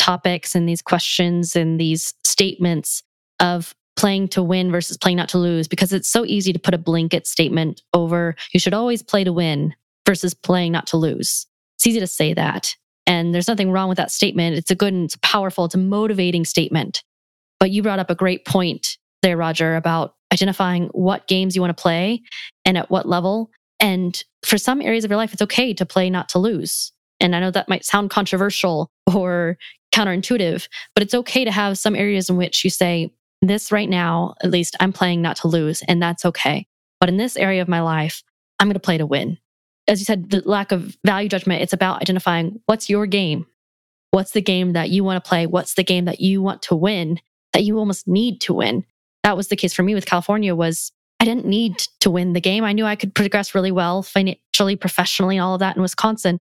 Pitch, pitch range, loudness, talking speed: 185 Hz, 175-200 Hz, -19 LUFS, 220 wpm